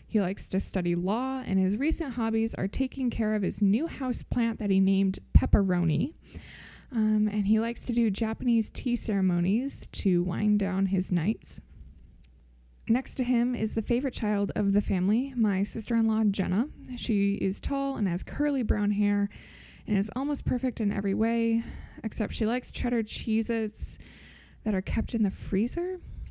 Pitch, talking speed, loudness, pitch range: 215 Hz, 175 wpm, -28 LUFS, 195-240 Hz